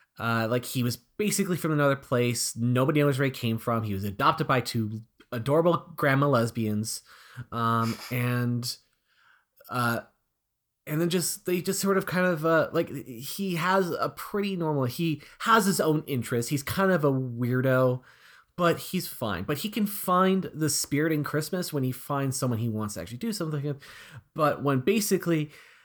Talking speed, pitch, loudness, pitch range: 175 wpm, 145 Hz, -27 LUFS, 120-175 Hz